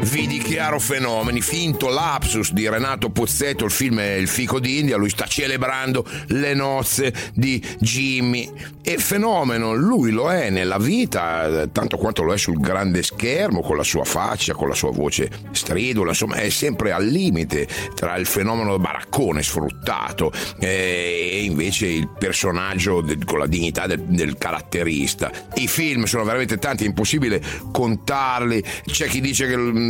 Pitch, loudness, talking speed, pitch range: 115 Hz, -20 LUFS, 155 wpm, 95-135 Hz